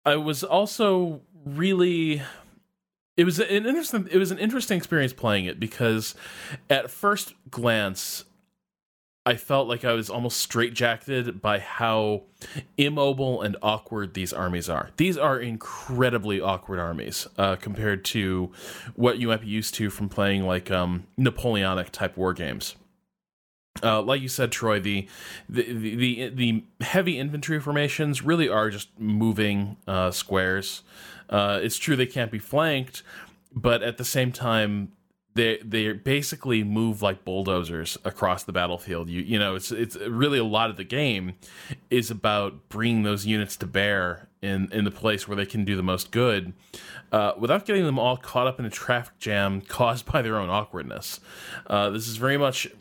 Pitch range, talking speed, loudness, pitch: 100-135 Hz, 165 wpm, -25 LUFS, 115 Hz